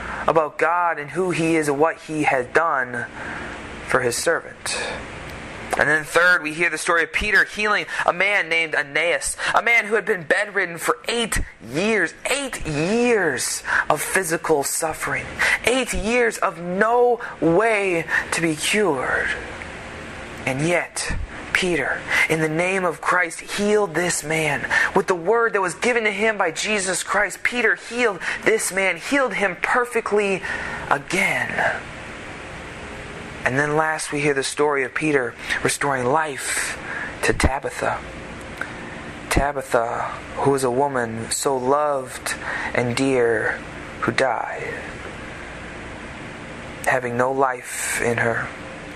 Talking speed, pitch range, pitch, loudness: 135 wpm, 140-205 Hz, 165 Hz, -21 LUFS